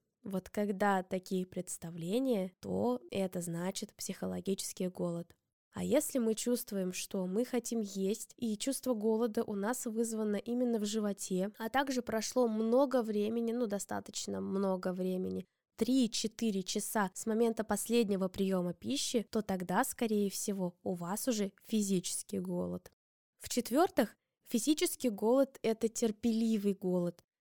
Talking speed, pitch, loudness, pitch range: 125 wpm, 210 Hz, -35 LUFS, 185-235 Hz